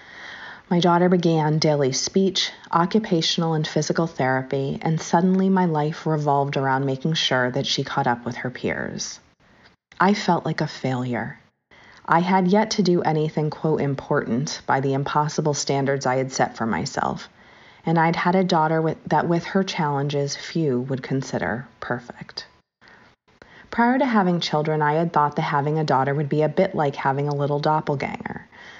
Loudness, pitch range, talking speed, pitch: -22 LUFS, 140-170 Hz, 165 wpm, 155 Hz